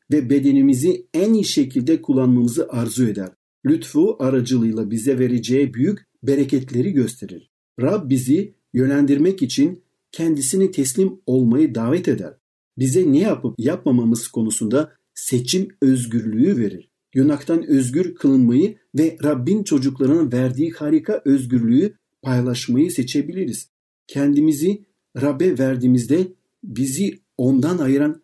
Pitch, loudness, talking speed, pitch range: 140 Hz, -19 LUFS, 105 wpm, 125-175 Hz